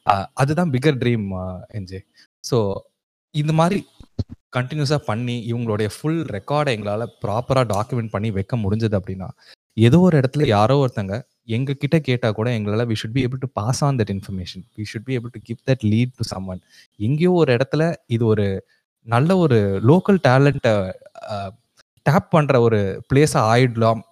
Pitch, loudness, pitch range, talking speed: 120 Hz, -20 LUFS, 105-140 Hz, 150 wpm